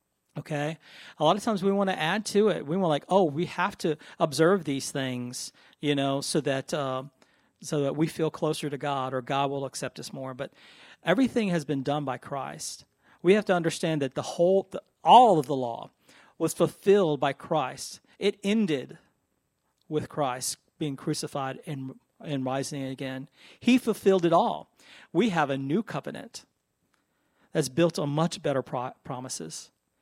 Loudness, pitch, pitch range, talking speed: -27 LUFS, 155 Hz, 140-180 Hz, 175 wpm